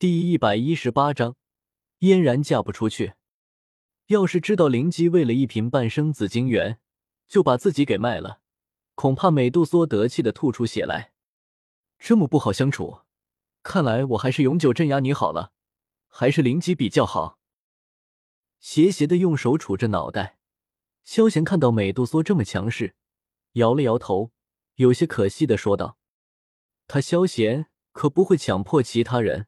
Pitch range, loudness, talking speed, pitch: 110-165 Hz, -22 LUFS, 230 characters per minute, 130 Hz